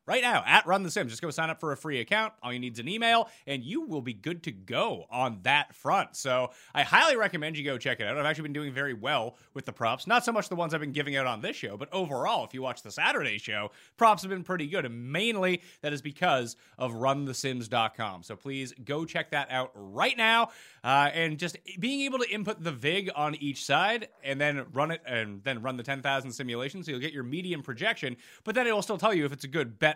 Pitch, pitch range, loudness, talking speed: 145 Hz, 130-175 Hz, -29 LUFS, 255 wpm